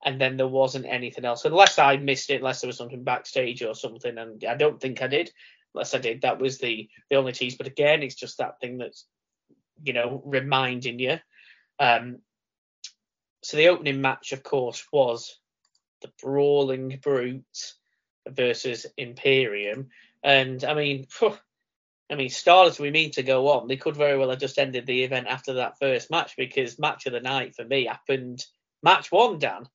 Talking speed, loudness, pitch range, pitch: 185 wpm, -24 LUFS, 125-140 Hz, 130 Hz